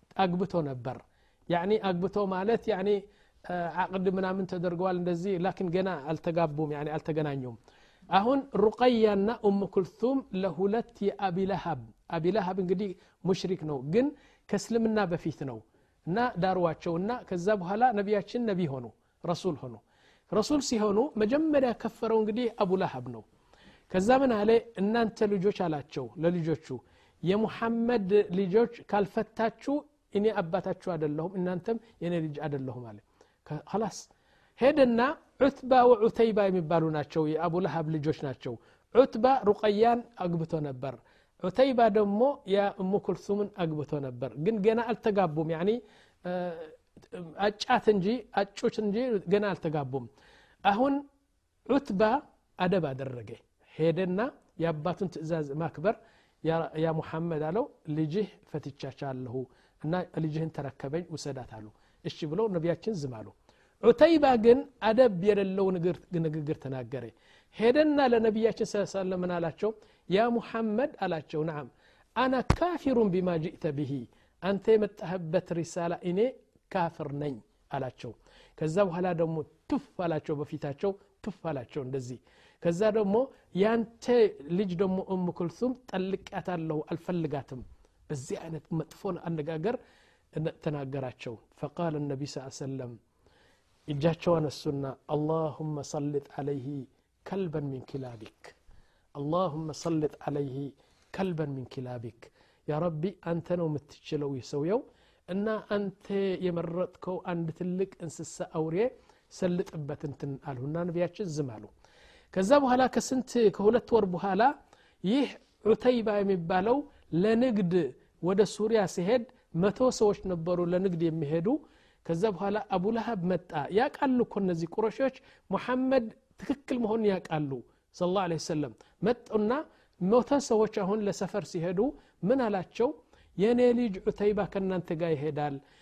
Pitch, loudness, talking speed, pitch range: 185 Hz, -30 LUFS, 110 wpm, 155-220 Hz